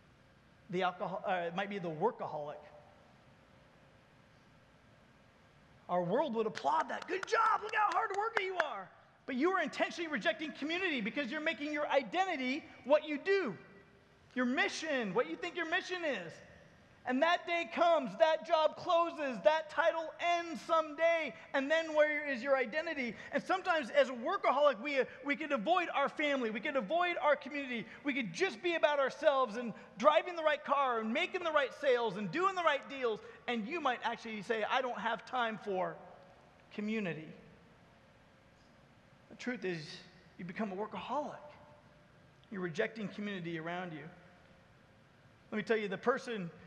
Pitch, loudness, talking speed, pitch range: 275 Hz, -34 LUFS, 160 wpm, 220-320 Hz